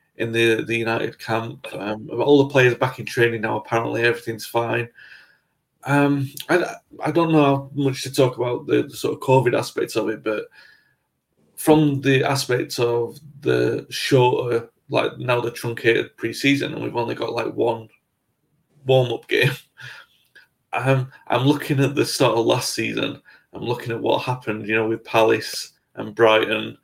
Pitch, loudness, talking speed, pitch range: 125 Hz, -21 LUFS, 170 wpm, 115-140 Hz